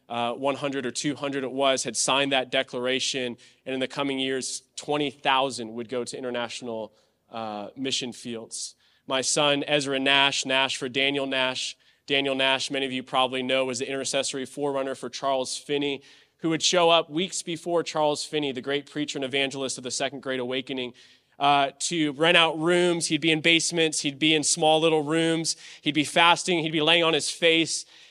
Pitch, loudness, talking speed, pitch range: 140 Hz, -24 LUFS, 185 wpm, 130-155 Hz